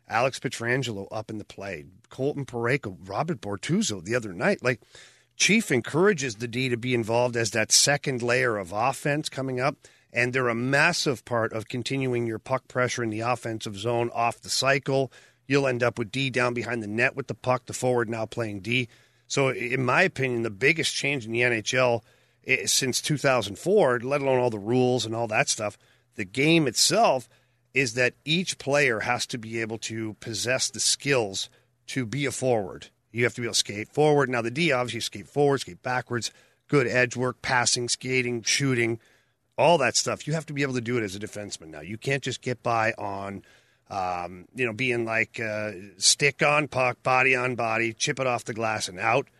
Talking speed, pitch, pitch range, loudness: 200 wpm, 120 Hz, 115-130 Hz, -25 LUFS